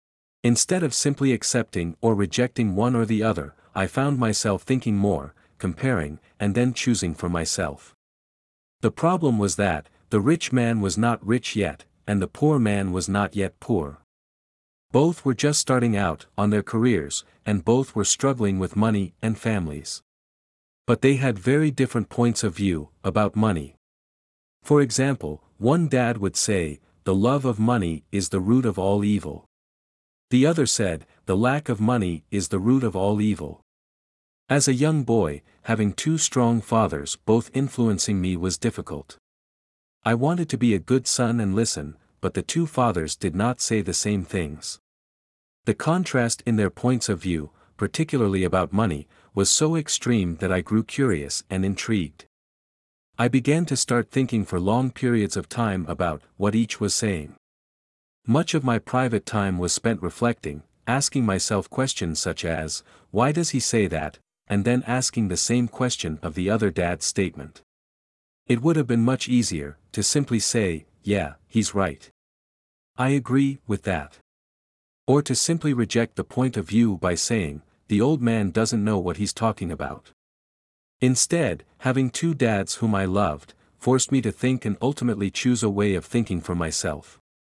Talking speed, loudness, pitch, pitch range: 170 wpm, -23 LUFS, 105 Hz, 90-125 Hz